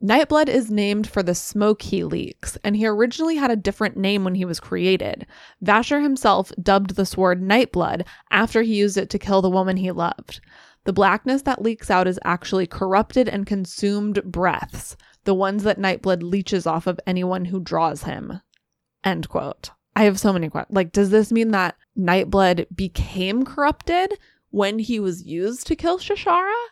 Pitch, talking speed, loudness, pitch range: 200 Hz, 175 wpm, -21 LUFS, 185-230 Hz